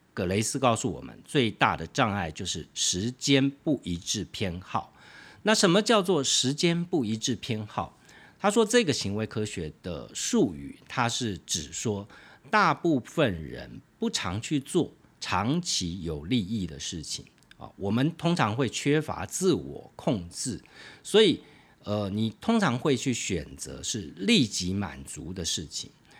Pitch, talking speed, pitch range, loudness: 110 Hz, 215 characters per minute, 95-140 Hz, -27 LUFS